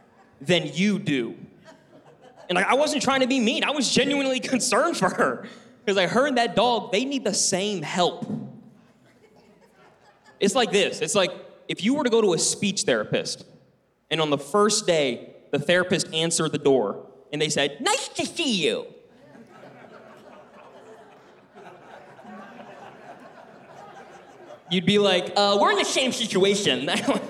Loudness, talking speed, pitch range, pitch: -23 LUFS, 150 wpm, 180-255 Hz, 205 Hz